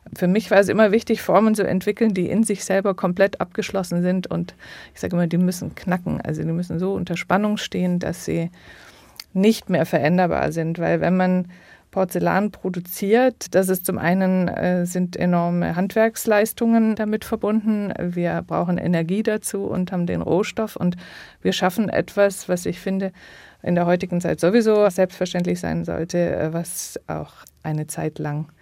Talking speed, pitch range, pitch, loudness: 165 wpm, 175-205 Hz, 185 Hz, -21 LUFS